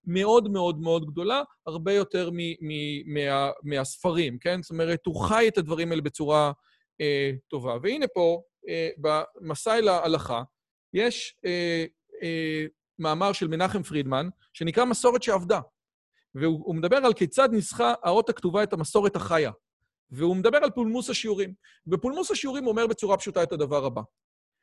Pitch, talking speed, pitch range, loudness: 175 Hz, 150 wpm, 155-215 Hz, -26 LUFS